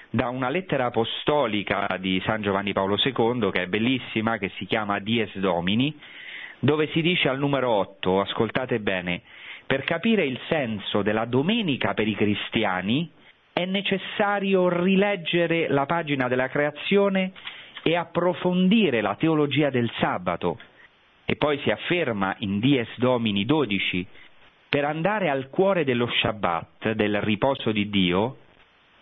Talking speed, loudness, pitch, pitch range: 135 wpm, -24 LUFS, 125 Hz, 105-160 Hz